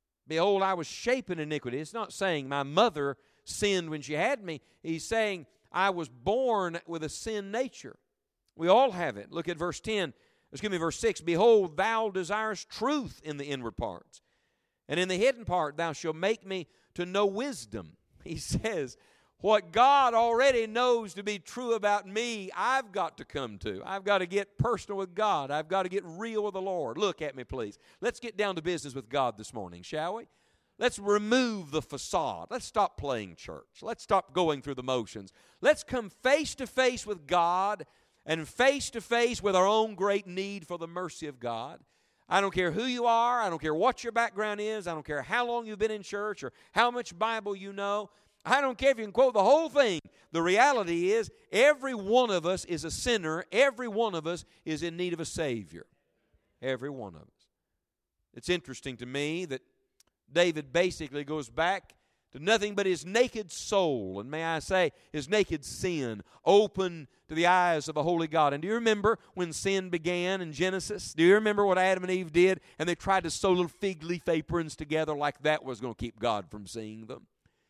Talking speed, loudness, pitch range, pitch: 205 wpm, -29 LUFS, 155-215 Hz, 185 Hz